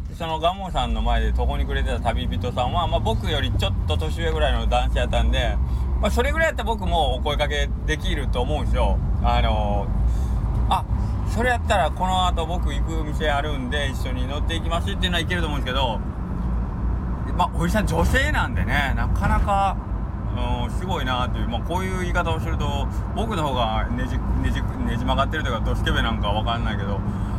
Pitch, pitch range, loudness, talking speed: 95 Hz, 75-105 Hz, -23 LUFS, 405 characters per minute